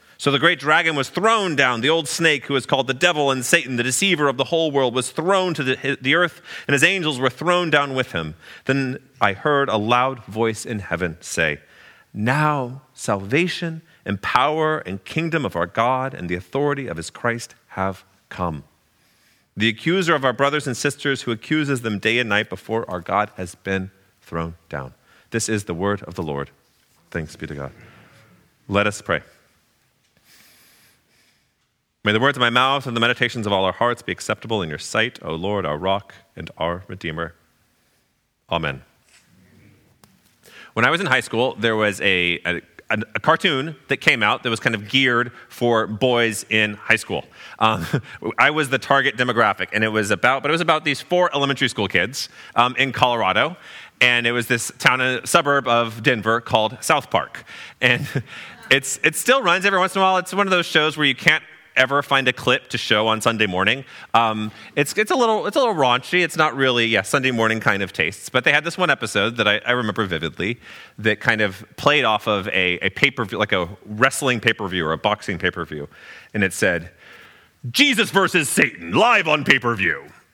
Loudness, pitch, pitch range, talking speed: -20 LUFS, 125 Hz, 105-145 Hz, 200 wpm